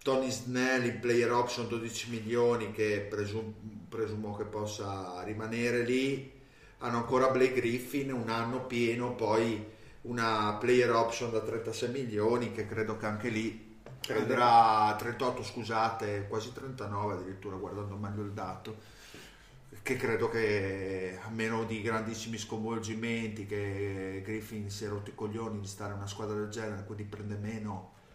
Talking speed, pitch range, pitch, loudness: 145 wpm, 105-120 Hz, 110 Hz, -33 LUFS